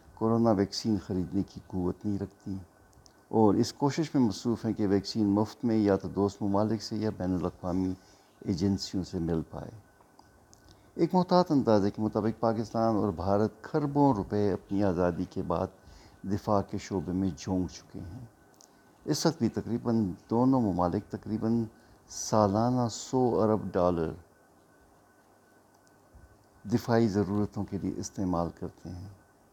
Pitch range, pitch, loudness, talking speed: 95-110 Hz, 100 Hz, -29 LUFS, 140 wpm